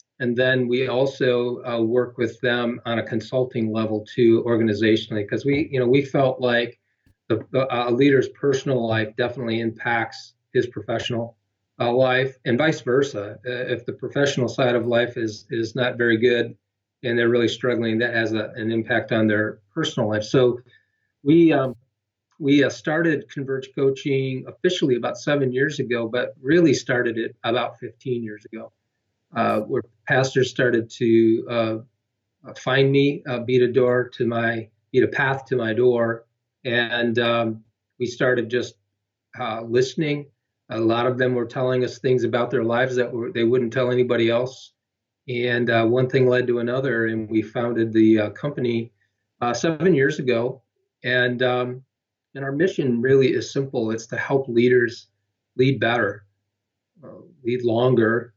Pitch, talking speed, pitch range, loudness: 120 Hz, 165 wpm, 115-130 Hz, -22 LUFS